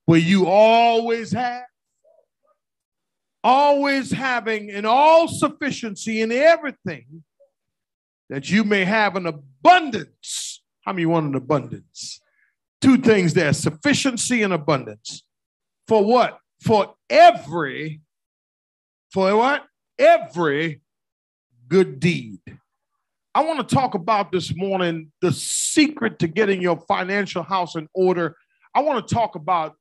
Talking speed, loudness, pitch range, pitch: 115 wpm, -19 LUFS, 165-250 Hz, 200 Hz